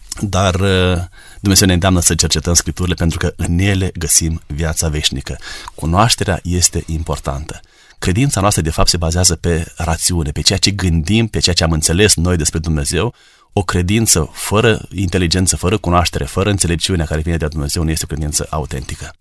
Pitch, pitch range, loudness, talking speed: 85 Hz, 80-95 Hz, -15 LUFS, 170 wpm